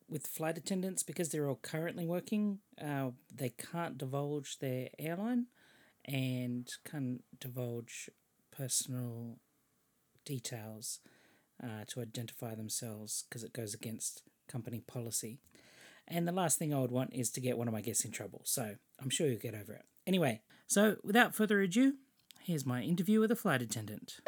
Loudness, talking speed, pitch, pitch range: -37 LUFS, 160 wpm, 130 Hz, 120-170 Hz